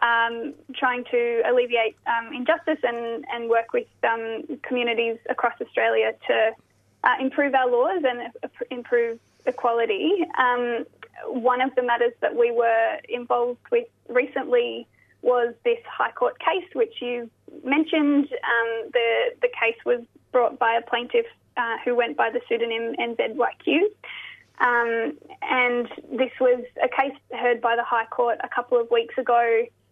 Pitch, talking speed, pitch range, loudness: 245 Hz, 145 wpm, 235-300 Hz, -23 LUFS